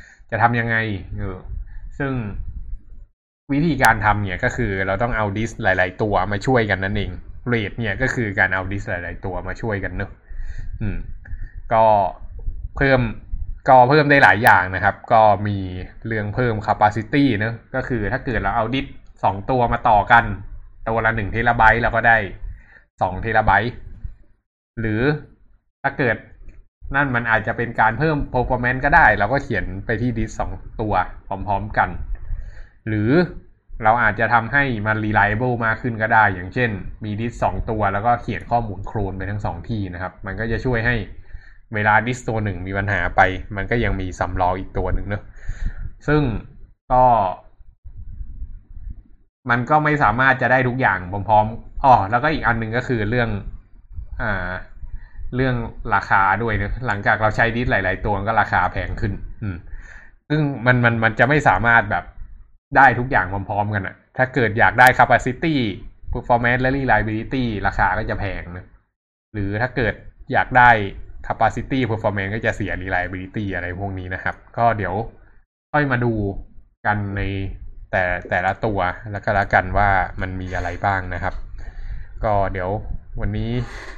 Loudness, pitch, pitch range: -19 LUFS, 105 Hz, 95-120 Hz